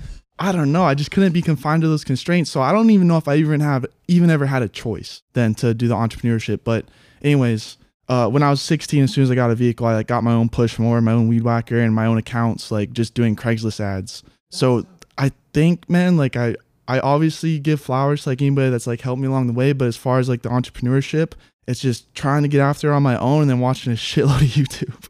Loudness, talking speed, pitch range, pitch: -19 LUFS, 255 wpm, 115-145 Hz, 130 Hz